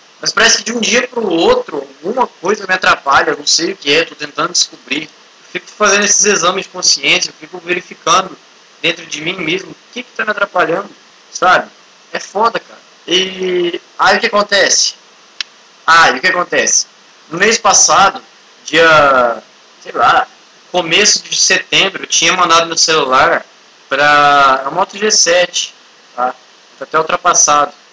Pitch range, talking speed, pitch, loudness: 165-210 Hz, 155 wpm, 180 Hz, -11 LUFS